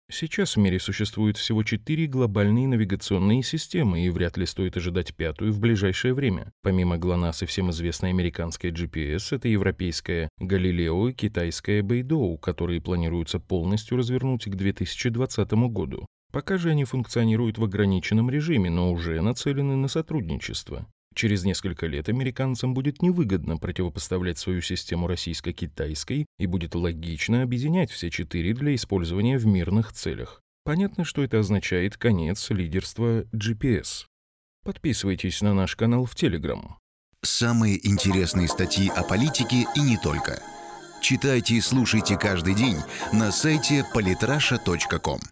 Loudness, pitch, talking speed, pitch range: -25 LUFS, 100 Hz, 130 wpm, 90-125 Hz